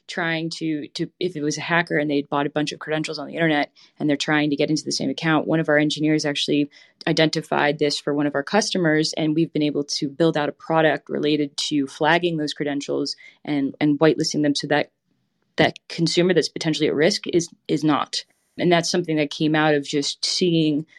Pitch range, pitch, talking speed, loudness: 145-165 Hz, 155 Hz, 220 wpm, -22 LUFS